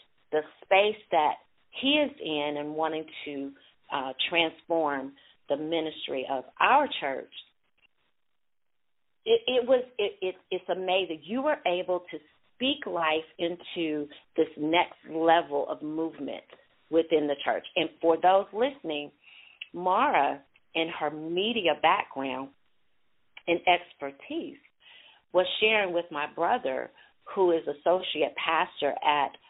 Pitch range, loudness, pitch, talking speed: 155-190 Hz, -28 LUFS, 165 Hz, 115 wpm